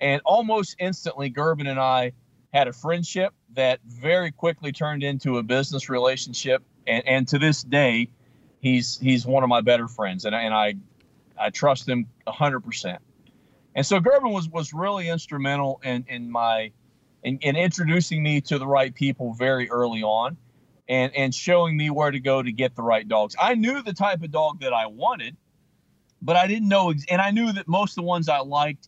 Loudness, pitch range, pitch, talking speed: -23 LUFS, 125-165 Hz, 140 Hz, 195 wpm